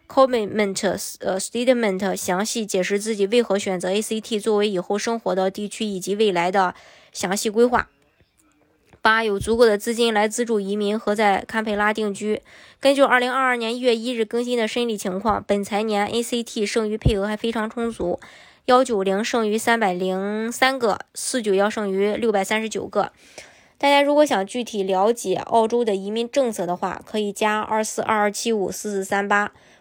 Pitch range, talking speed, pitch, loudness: 200-235 Hz, 305 characters per minute, 215 Hz, -21 LUFS